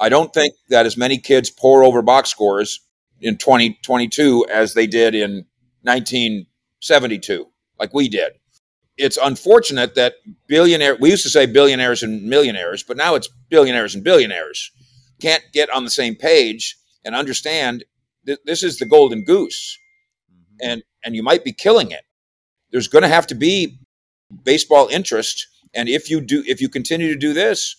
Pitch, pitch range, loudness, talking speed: 135 Hz, 120-160 Hz, -15 LUFS, 165 wpm